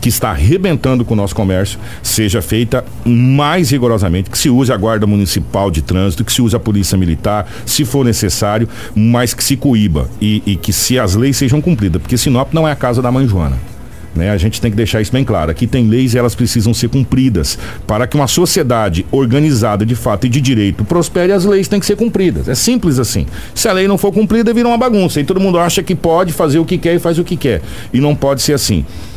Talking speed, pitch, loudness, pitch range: 235 wpm, 120 Hz, -13 LUFS, 105-150 Hz